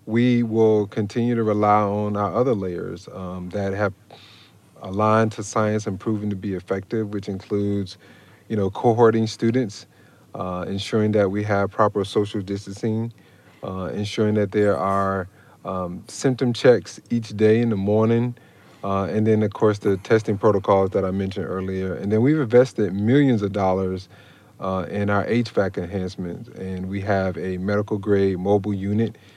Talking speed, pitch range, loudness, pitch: 160 wpm, 95-110 Hz, -22 LUFS, 105 Hz